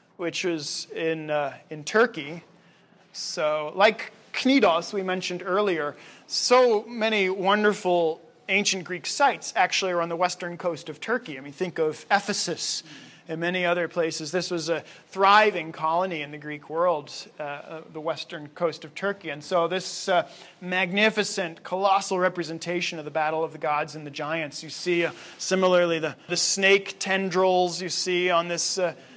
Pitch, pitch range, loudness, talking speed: 175 Hz, 160-190 Hz, -25 LUFS, 165 wpm